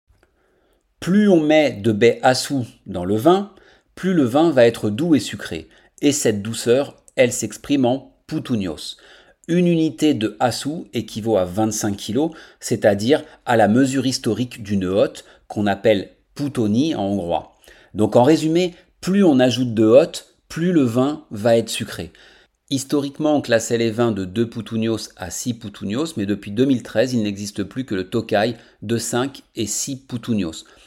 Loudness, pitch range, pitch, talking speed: -20 LUFS, 110-140 Hz, 115 Hz, 160 wpm